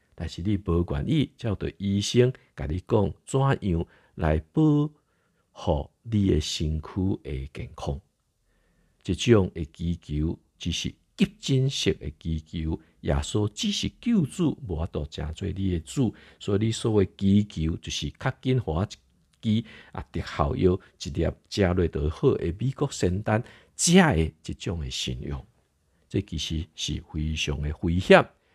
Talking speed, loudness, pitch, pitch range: 195 characters per minute, -27 LUFS, 90 Hz, 80-110 Hz